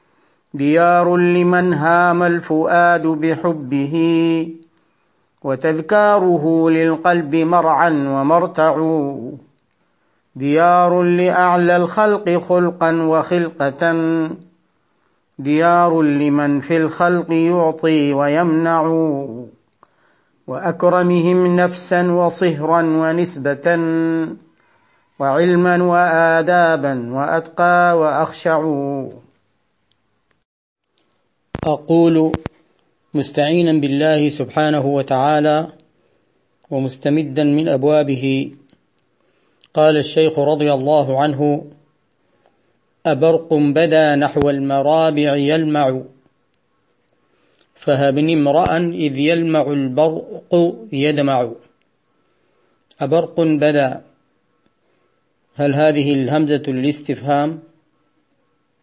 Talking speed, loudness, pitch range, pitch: 60 wpm, -16 LUFS, 145-170 Hz, 160 Hz